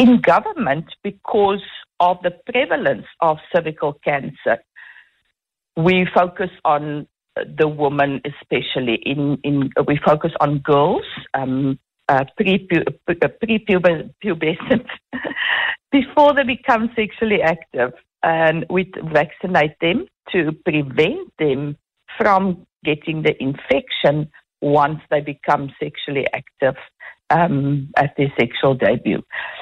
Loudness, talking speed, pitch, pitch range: -19 LUFS, 105 wpm, 160 Hz, 145-195 Hz